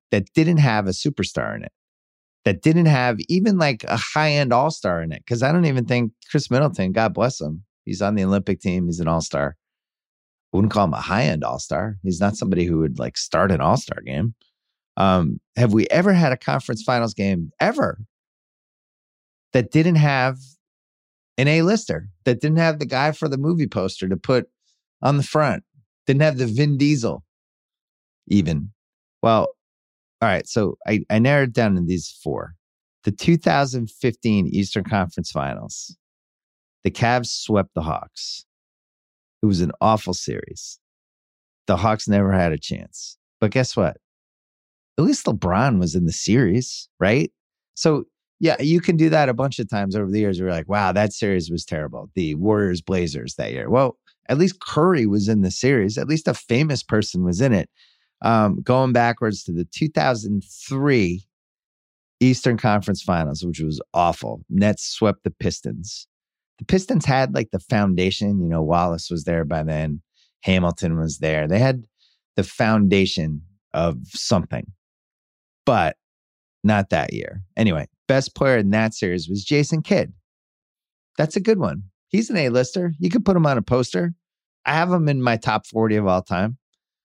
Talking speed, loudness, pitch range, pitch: 170 wpm, -21 LUFS, 90-135 Hz, 110 Hz